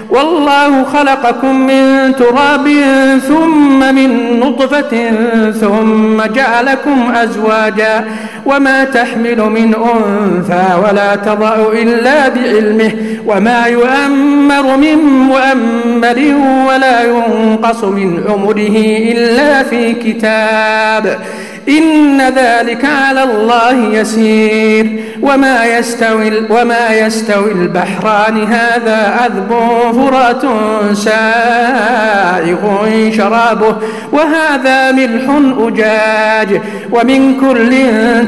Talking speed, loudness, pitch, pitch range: 75 wpm, -9 LUFS, 235 Hz, 220-265 Hz